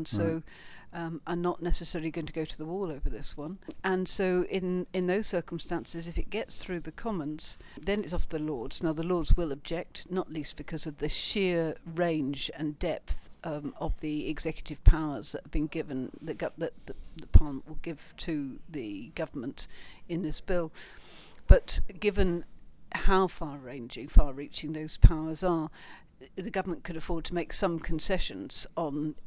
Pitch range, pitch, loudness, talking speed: 155-180 Hz, 165 Hz, -32 LUFS, 175 wpm